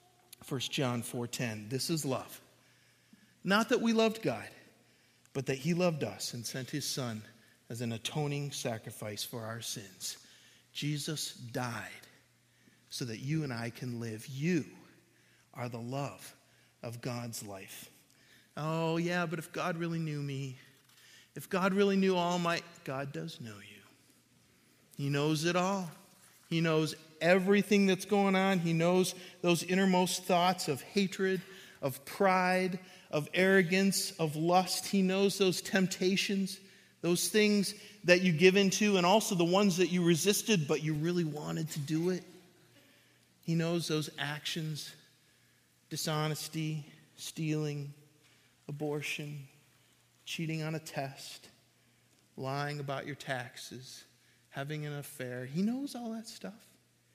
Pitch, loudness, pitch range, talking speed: 155 Hz, -32 LUFS, 135-185 Hz, 140 wpm